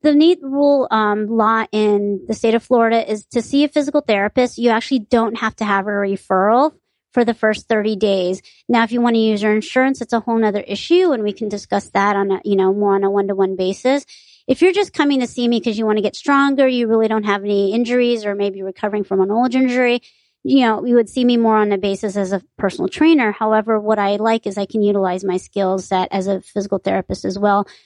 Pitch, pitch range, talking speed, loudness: 220 Hz, 200-245 Hz, 245 wpm, -17 LUFS